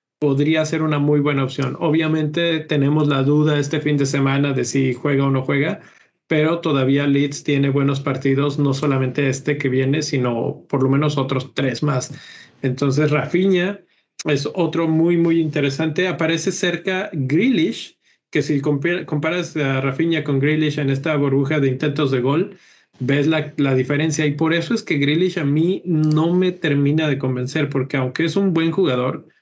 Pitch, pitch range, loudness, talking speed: 150 Hz, 140-160 Hz, -19 LUFS, 175 wpm